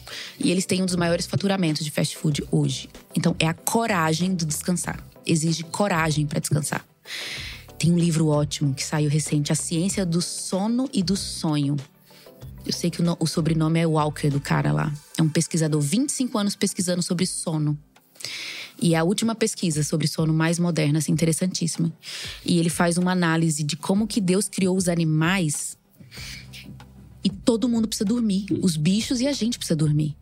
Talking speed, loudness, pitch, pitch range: 175 wpm, -23 LUFS, 165 Hz, 155-190 Hz